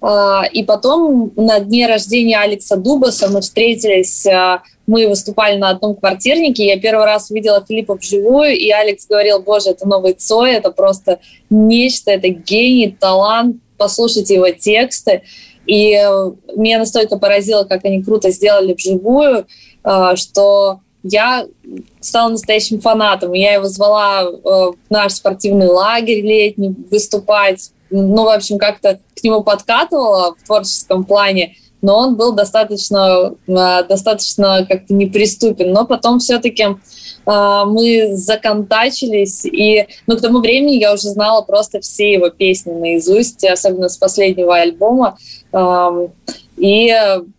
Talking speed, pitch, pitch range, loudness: 130 wpm, 205 Hz, 195-220 Hz, -12 LUFS